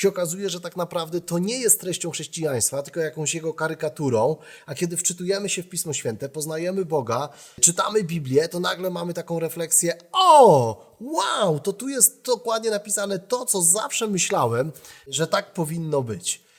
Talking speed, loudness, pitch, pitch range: 165 wpm, -22 LUFS, 175 Hz, 160-195 Hz